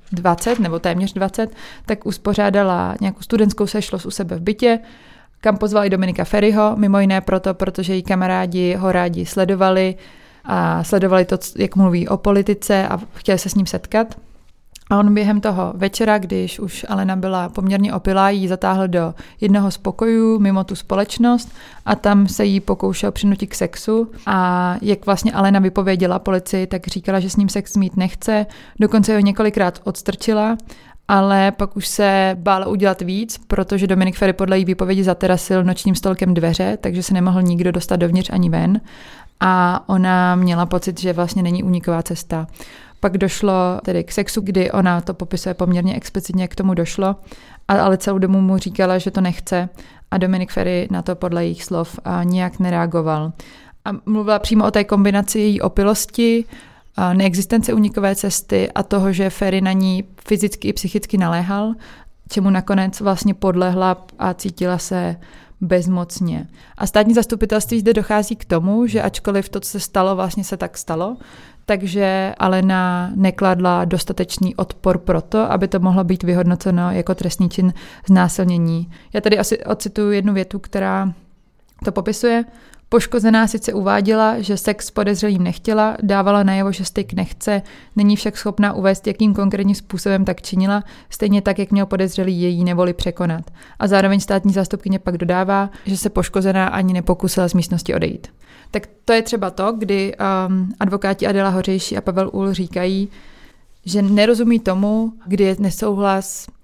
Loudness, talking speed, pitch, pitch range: -18 LUFS, 160 wpm, 195 Hz, 185-205 Hz